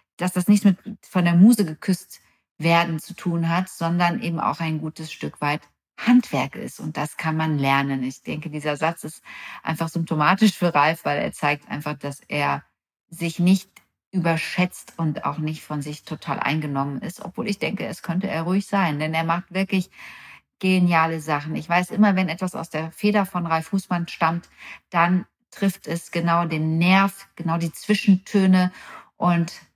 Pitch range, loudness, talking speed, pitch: 155-190 Hz, -22 LUFS, 175 wpm, 170 Hz